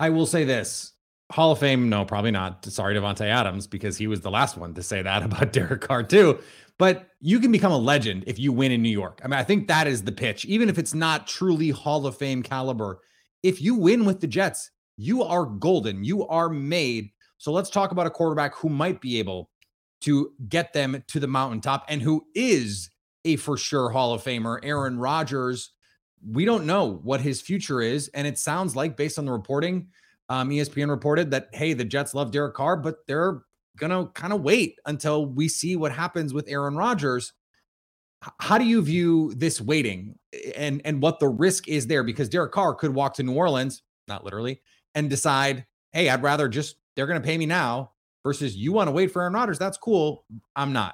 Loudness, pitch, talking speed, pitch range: -24 LUFS, 145 Hz, 210 wpm, 125-165 Hz